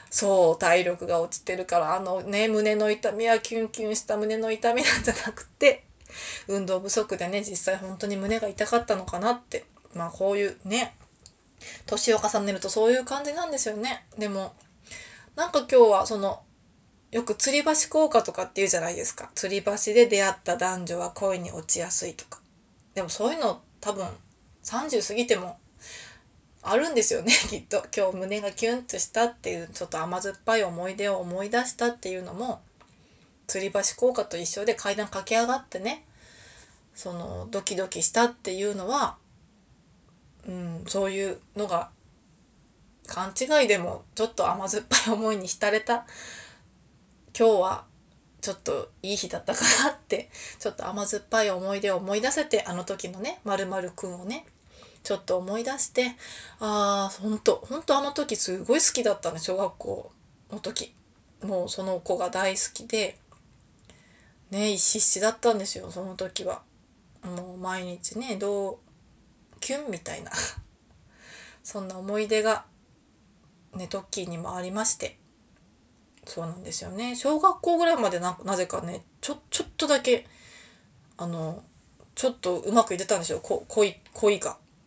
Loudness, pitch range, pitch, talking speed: -25 LUFS, 190-230 Hz, 205 Hz, 315 characters per minute